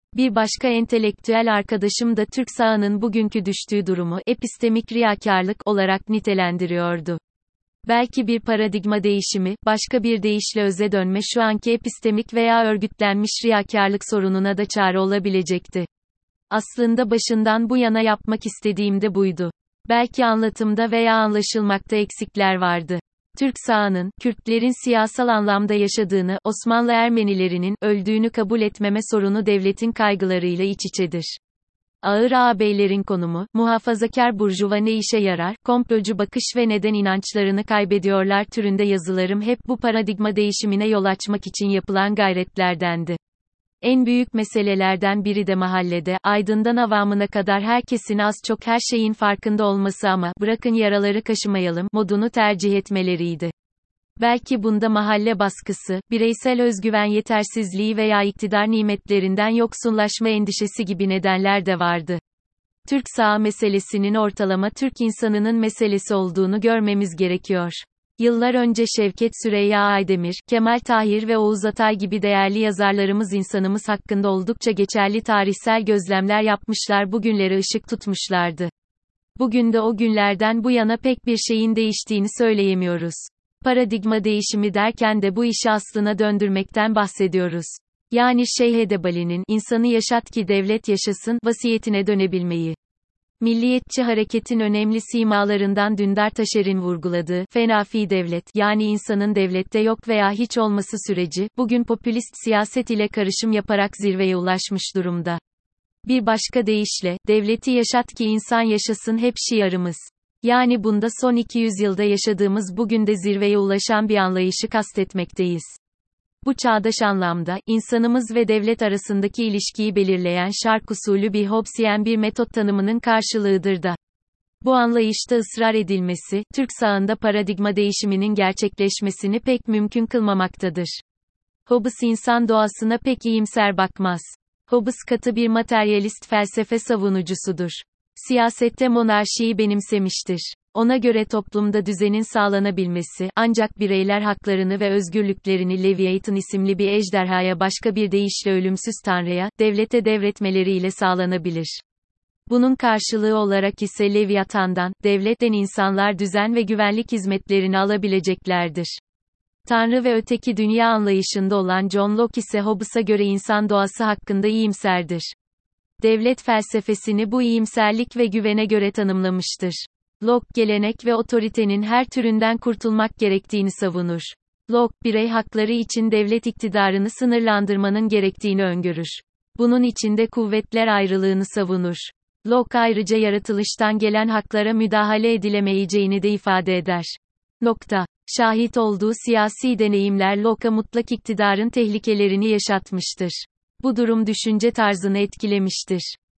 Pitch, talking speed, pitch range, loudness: 210 Hz, 120 wpm, 195-225 Hz, -20 LUFS